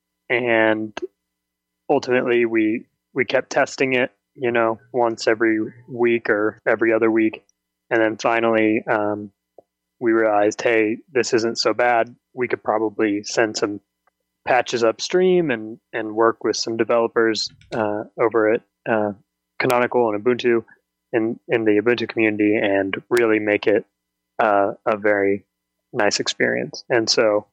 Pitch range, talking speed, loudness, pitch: 105-115 Hz, 135 wpm, -20 LUFS, 110 Hz